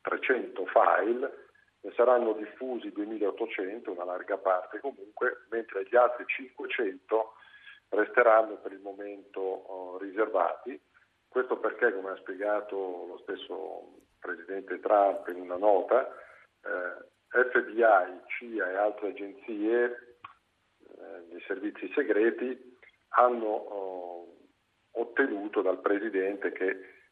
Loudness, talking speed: -30 LUFS, 105 wpm